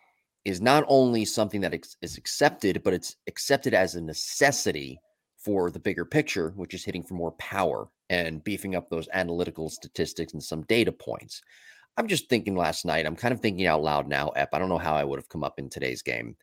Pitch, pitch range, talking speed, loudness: 90 Hz, 80-105 Hz, 210 wpm, -27 LUFS